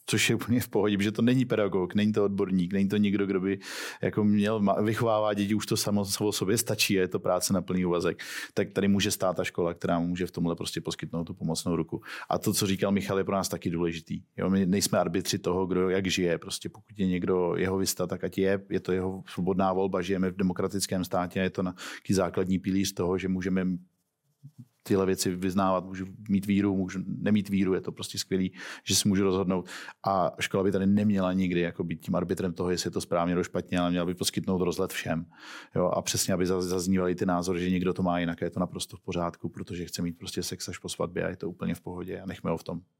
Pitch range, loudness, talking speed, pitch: 90-100 Hz, -28 LUFS, 240 wpm, 95 Hz